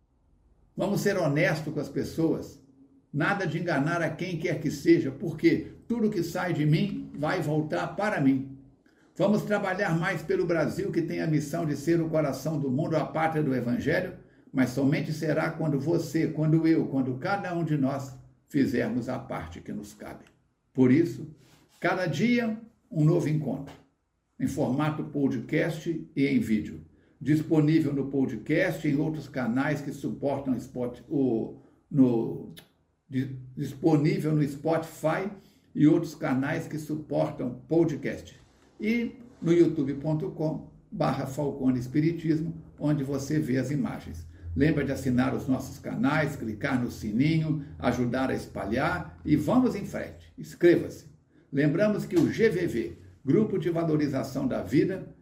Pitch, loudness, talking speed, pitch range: 150 Hz, -28 LUFS, 140 wpm, 135-165 Hz